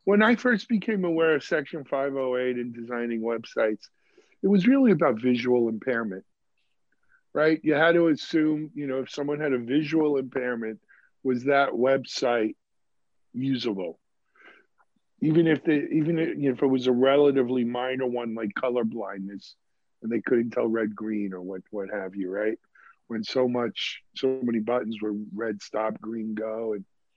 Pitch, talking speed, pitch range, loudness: 130 Hz, 165 wpm, 115-150 Hz, -26 LUFS